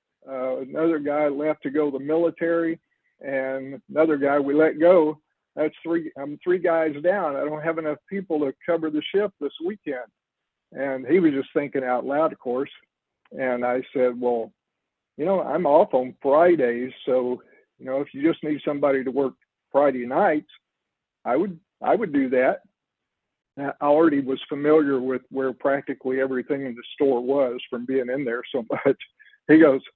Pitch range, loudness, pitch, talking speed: 130-160 Hz, -23 LUFS, 145 Hz, 180 wpm